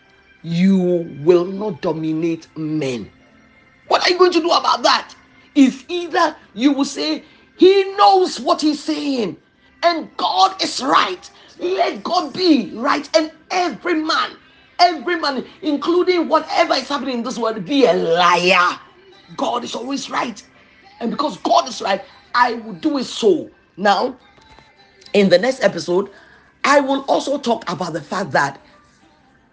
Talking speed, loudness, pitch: 150 wpm, -18 LUFS, 275 Hz